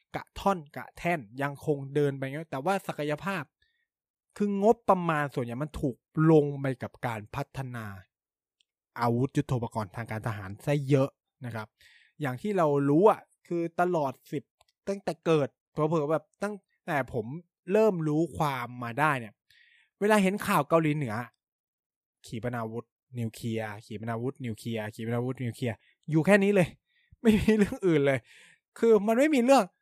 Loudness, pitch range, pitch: -28 LUFS, 120-180 Hz, 145 Hz